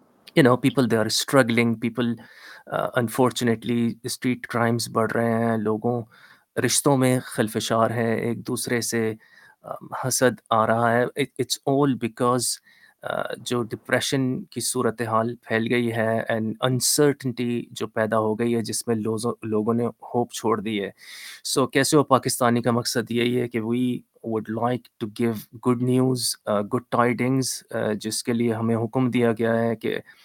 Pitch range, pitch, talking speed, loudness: 115-125 Hz, 120 Hz, 160 wpm, -23 LUFS